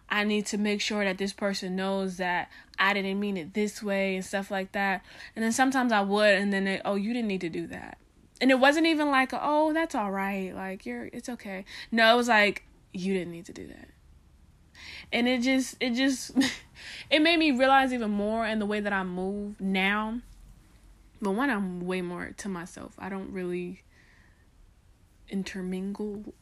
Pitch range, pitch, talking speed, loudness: 185-235 Hz, 200 Hz, 200 wpm, -27 LUFS